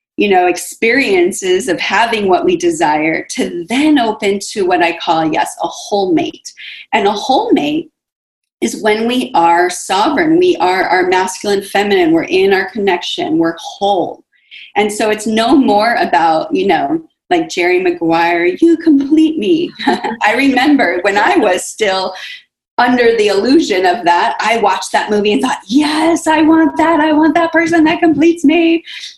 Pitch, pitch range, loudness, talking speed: 300 Hz, 205-335 Hz, -12 LUFS, 165 wpm